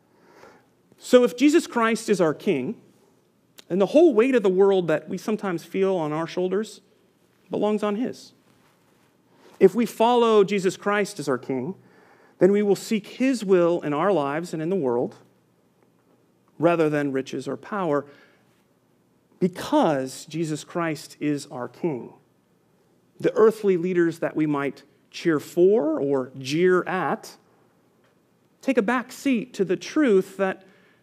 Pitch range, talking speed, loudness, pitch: 155-215 Hz, 145 wpm, -23 LUFS, 190 Hz